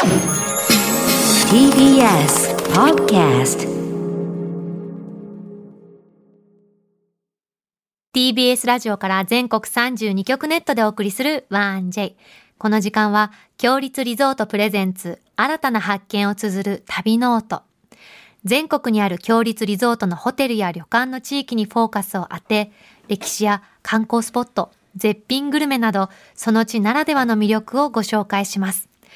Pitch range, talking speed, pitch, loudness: 200-240 Hz, 260 characters per minute, 210 Hz, -18 LUFS